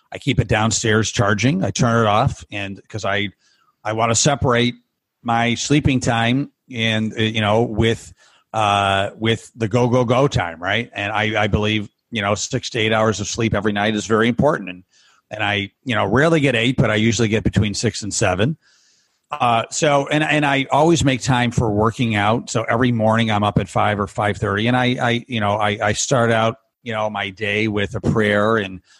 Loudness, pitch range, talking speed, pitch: -18 LUFS, 105-120 Hz, 210 wpm, 110 Hz